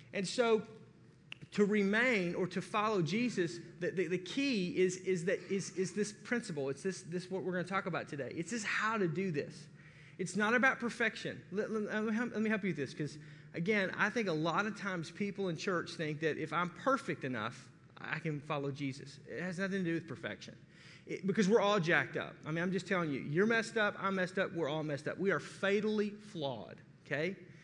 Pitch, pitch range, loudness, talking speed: 185 Hz, 160-205 Hz, -35 LUFS, 230 wpm